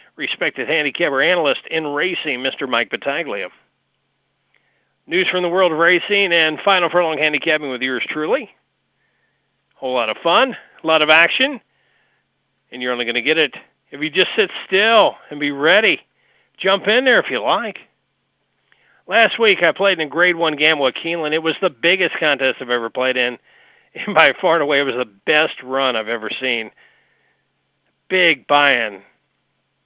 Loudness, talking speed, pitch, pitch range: -16 LUFS, 175 wpm, 160 Hz, 140-185 Hz